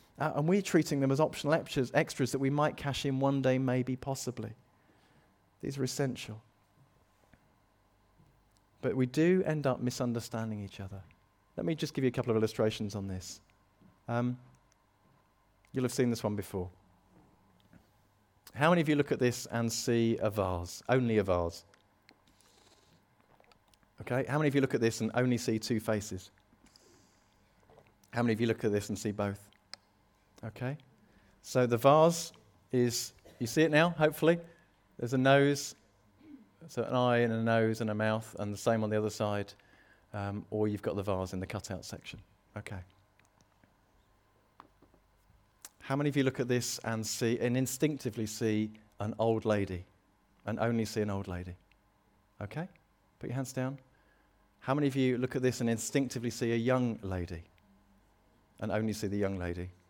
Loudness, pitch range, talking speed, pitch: -32 LUFS, 105-130 Hz, 170 wpm, 110 Hz